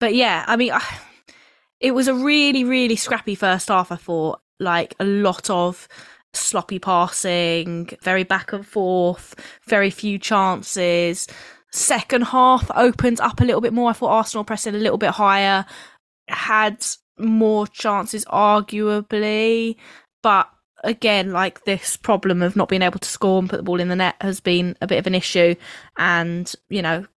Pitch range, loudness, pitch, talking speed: 180-225 Hz, -19 LUFS, 200 Hz, 165 wpm